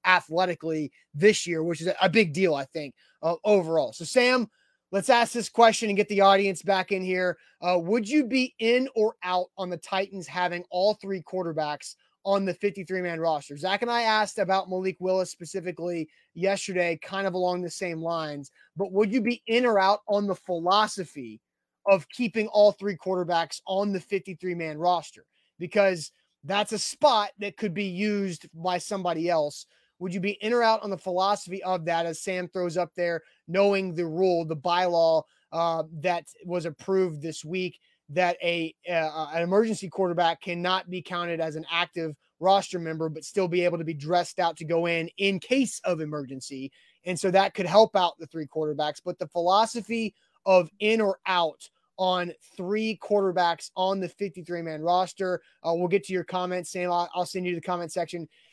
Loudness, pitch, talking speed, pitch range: -26 LUFS, 180 Hz, 190 wpm, 170-195 Hz